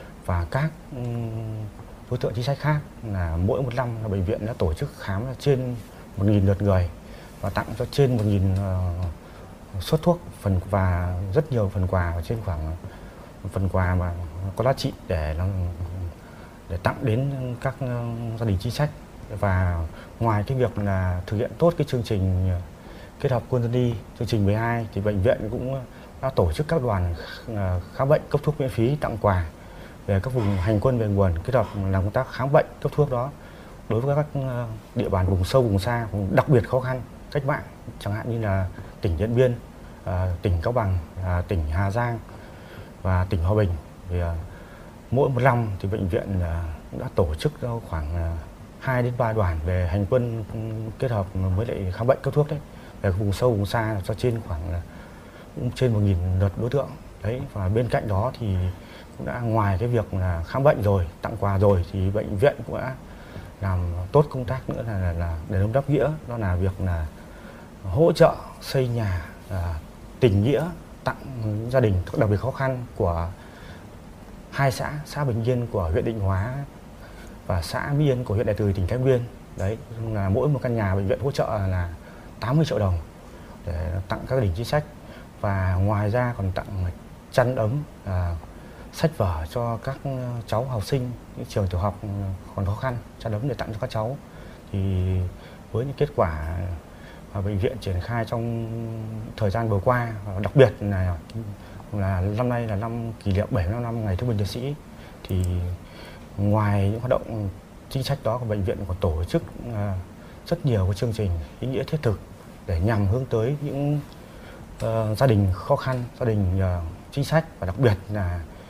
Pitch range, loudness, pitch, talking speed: 95-125 Hz, -25 LUFS, 105 Hz, 190 wpm